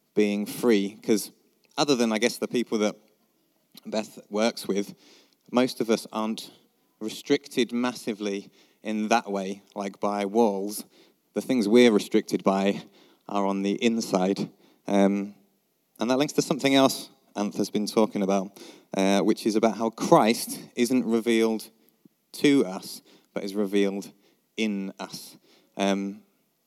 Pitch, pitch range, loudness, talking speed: 105 Hz, 100-115 Hz, -26 LUFS, 135 wpm